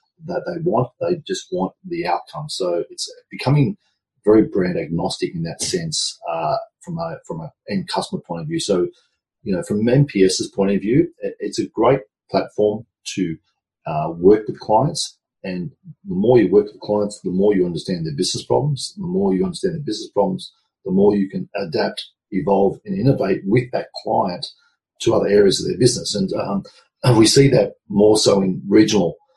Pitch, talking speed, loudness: 165 Hz, 190 wpm, -19 LUFS